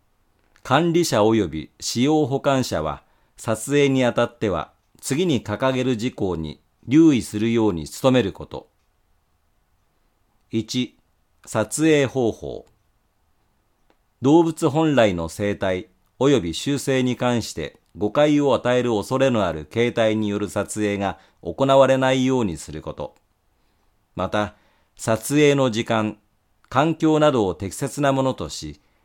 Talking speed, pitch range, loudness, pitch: 225 characters per minute, 95-130 Hz, -21 LUFS, 110 Hz